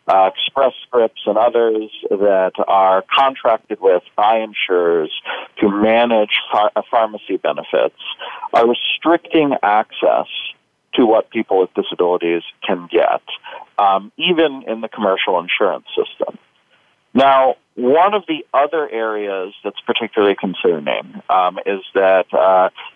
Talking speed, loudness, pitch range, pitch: 120 wpm, -16 LUFS, 95-135 Hz, 110 Hz